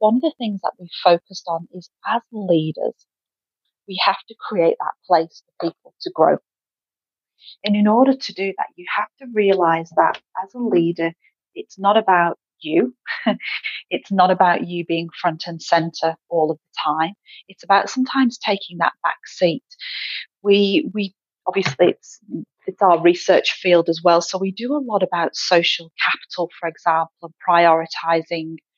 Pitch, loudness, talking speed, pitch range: 180 Hz, -19 LUFS, 165 wpm, 170-210 Hz